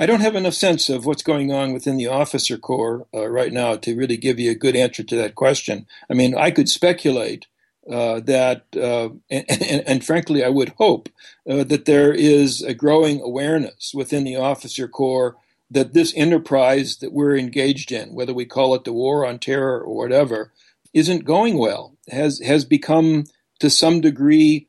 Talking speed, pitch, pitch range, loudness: 190 wpm, 140 Hz, 130-150 Hz, -19 LUFS